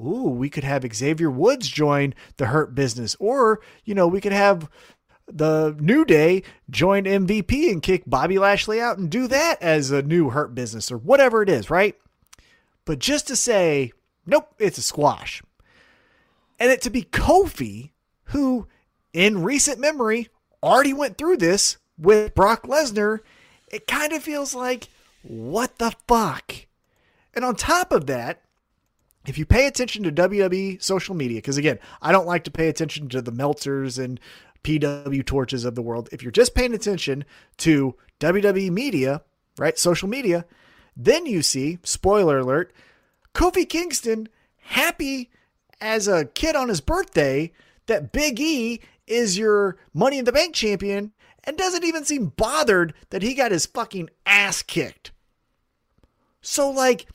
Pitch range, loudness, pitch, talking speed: 155-250 Hz, -21 LUFS, 200 Hz, 160 wpm